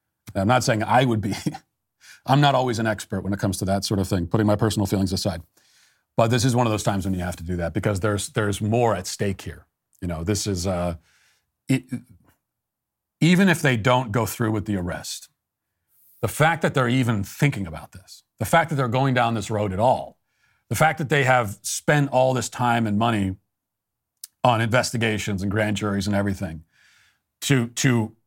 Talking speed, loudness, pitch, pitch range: 205 wpm, -22 LUFS, 110 Hz, 100-125 Hz